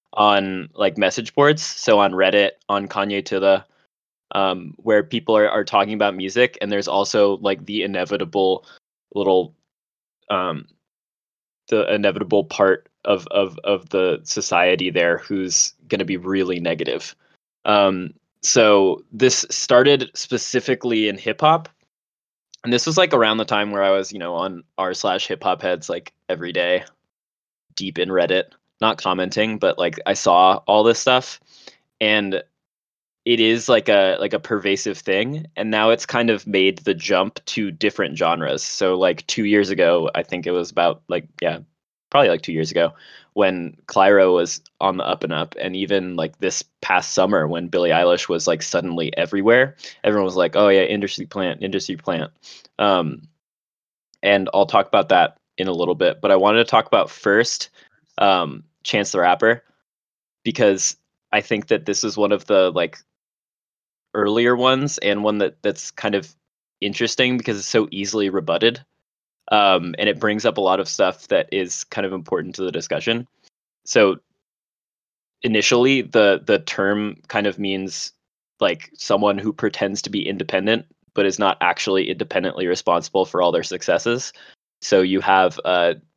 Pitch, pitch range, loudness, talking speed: 100 Hz, 95-110 Hz, -19 LUFS, 170 wpm